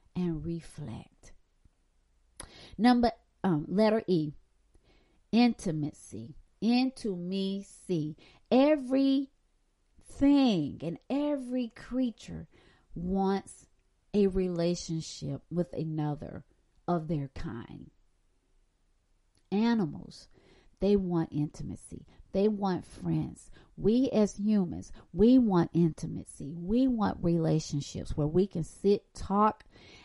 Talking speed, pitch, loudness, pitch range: 90 wpm, 175 Hz, -30 LUFS, 150-215 Hz